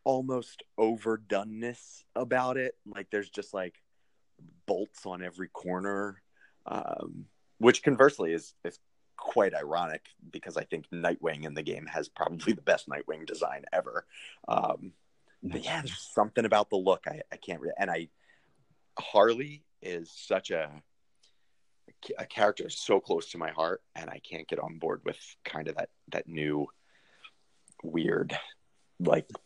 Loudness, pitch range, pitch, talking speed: -31 LUFS, 85-120 Hz, 100 Hz, 145 wpm